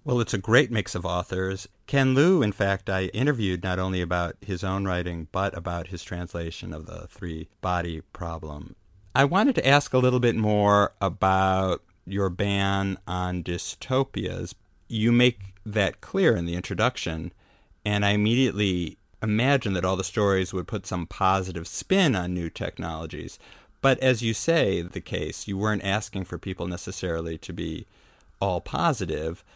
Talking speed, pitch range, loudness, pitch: 160 wpm, 90-105 Hz, -26 LUFS, 95 Hz